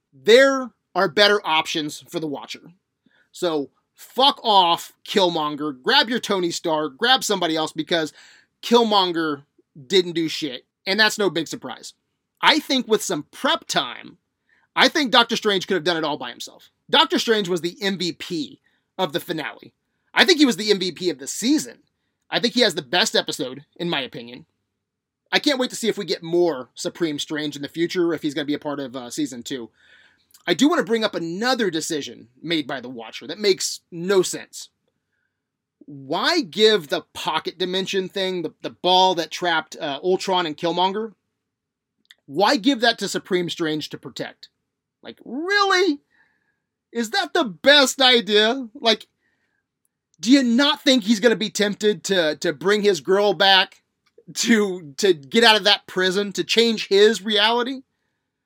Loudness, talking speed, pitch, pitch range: -20 LUFS, 175 wpm, 195 Hz, 165-235 Hz